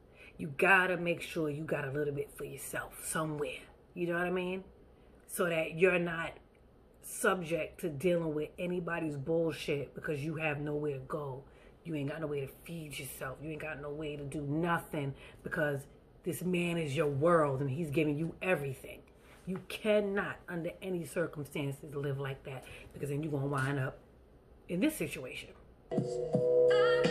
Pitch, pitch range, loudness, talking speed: 155 Hz, 145-175 Hz, -34 LUFS, 170 wpm